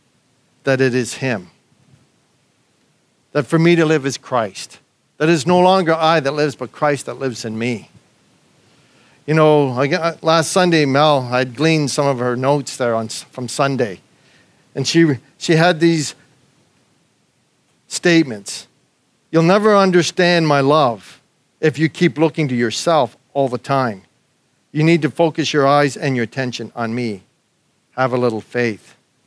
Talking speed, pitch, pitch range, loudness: 155 wpm, 145 Hz, 125-160 Hz, -17 LUFS